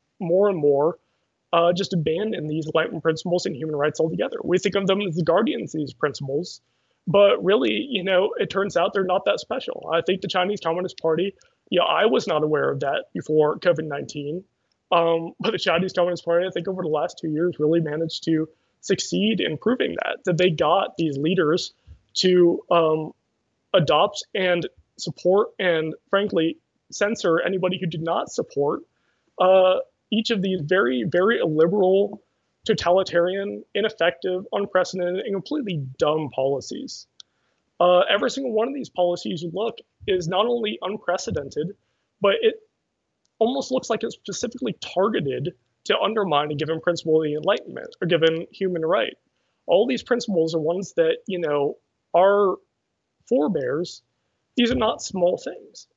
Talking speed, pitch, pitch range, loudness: 160 wpm, 180 Hz, 160-200 Hz, -23 LUFS